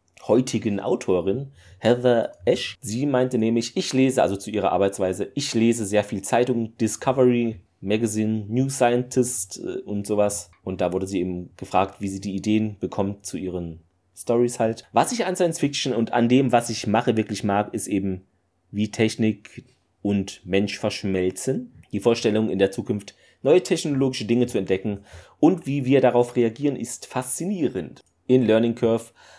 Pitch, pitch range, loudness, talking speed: 110 Hz, 100-125 Hz, -23 LUFS, 160 wpm